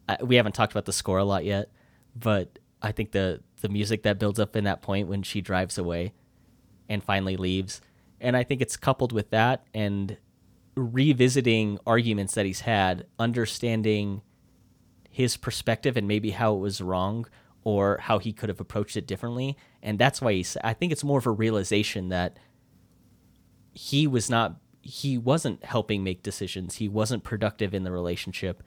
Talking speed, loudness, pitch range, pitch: 175 wpm, -27 LUFS, 100-120 Hz, 105 Hz